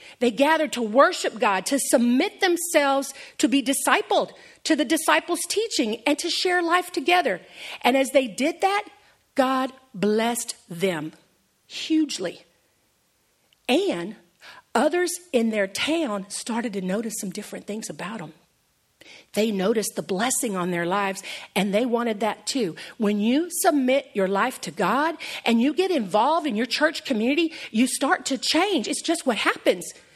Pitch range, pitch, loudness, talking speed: 210-315 Hz, 265 Hz, -23 LUFS, 155 wpm